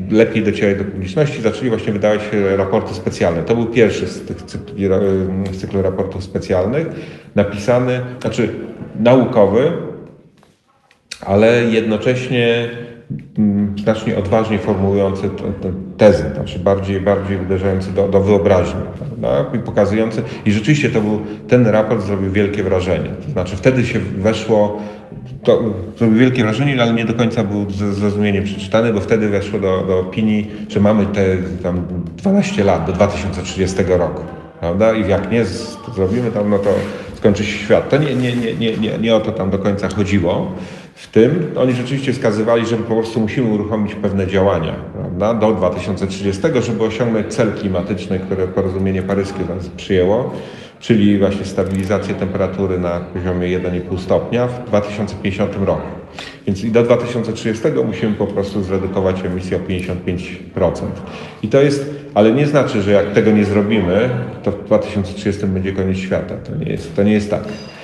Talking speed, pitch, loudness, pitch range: 155 wpm, 105 Hz, -17 LUFS, 95-115 Hz